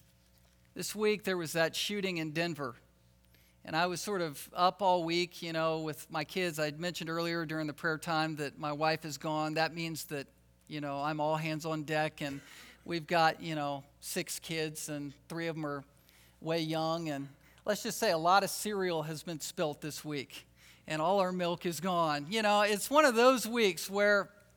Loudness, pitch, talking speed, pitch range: -33 LUFS, 160 Hz, 205 wpm, 145-180 Hz